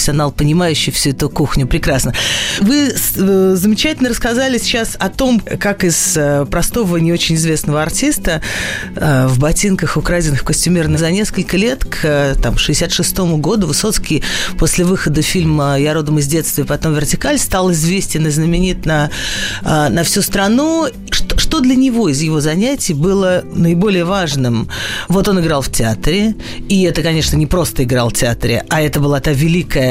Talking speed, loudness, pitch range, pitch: 150 wpm, -14 LUFS, 150-190 Hz, 165 Hz